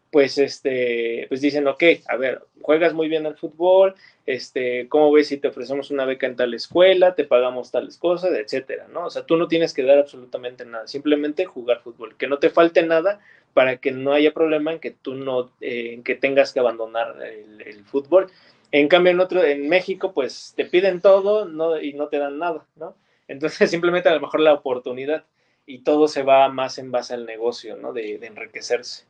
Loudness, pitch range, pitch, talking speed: -20 LUFS, 130-175 Hz, 150 Hz, 210 wpm